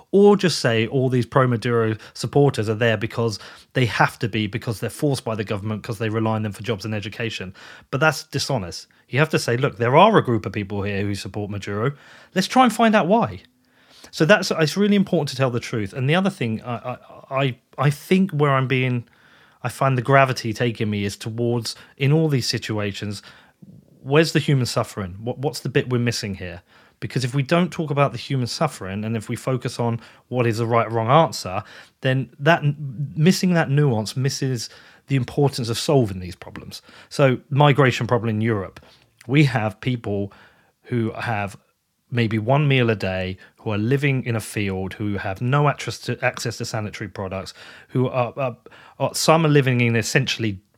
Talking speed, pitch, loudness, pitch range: 200 wpm, 120 Hz, -21 LUFS, 110-140 Hz